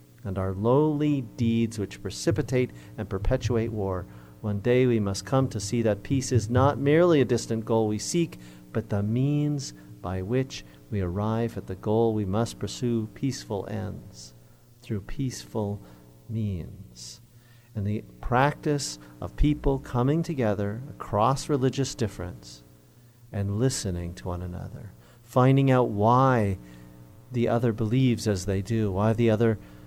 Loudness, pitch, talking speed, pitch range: -26 LUFS, 110 Hz, 145 wpm, 100-125 Hz